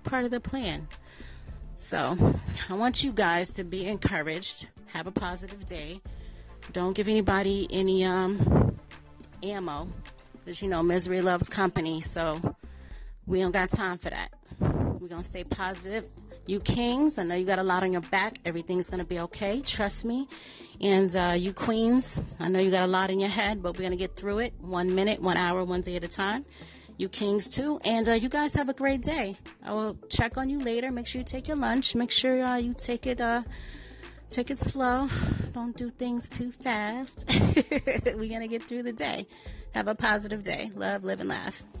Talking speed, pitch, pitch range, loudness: 200 wpm, 195 Hz, 180-240 Hz, -28 LUFS